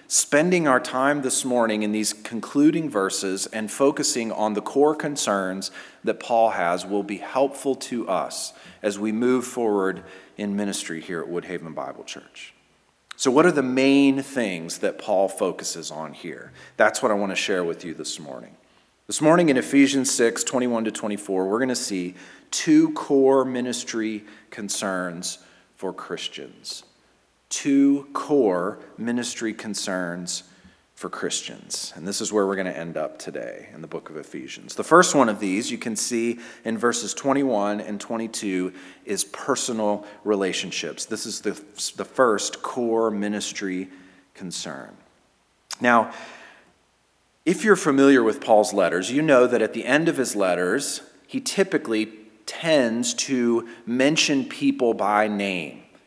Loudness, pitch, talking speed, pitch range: -23 LUFS, 110 Hz, 150 wpm, 100-135 Hz